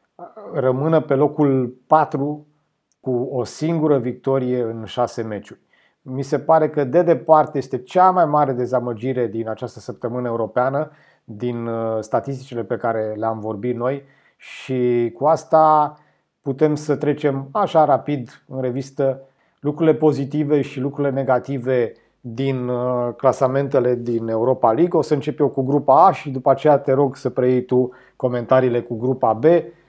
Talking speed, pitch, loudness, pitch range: 145 wpm, 135 Hz, -19 LUFS, 125-150 Hz